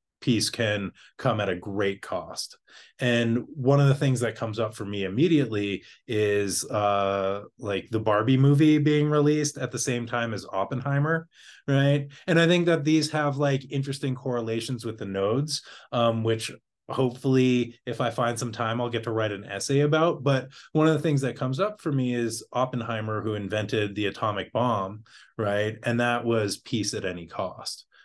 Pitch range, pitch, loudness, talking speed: 110-140 Hz, 120 Hz, -26 LUFS, 180 wpm